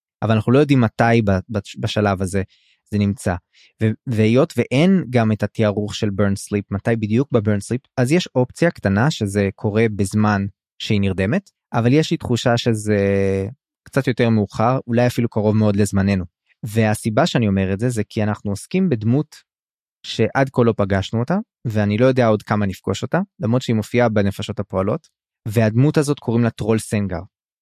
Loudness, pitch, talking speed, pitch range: -19 LUFS, 110 Hz, 165 wpm, 105-125 Hz